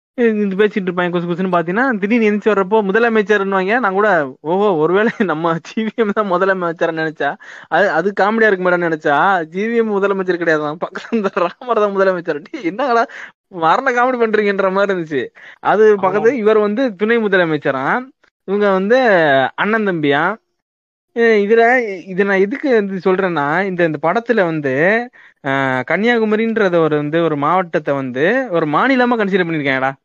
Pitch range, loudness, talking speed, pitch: 175-225 Hz, -15 LUFS, 130 wpm, 200 Hz